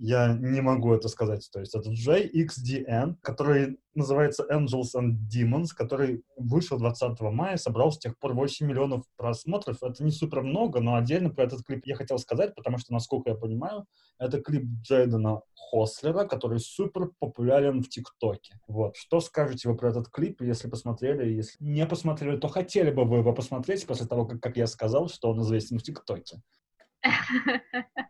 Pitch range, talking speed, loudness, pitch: 120-150 Hz, 170 wpm, -28 LUFS, 130 Hz